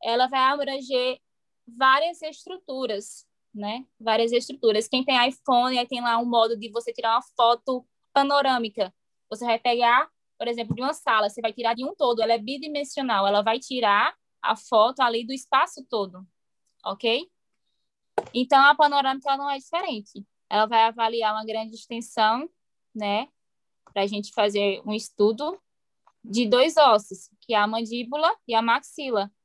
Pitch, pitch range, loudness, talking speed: 235 Hz, 220-265 Hz, -24 LUFS, 160 wpm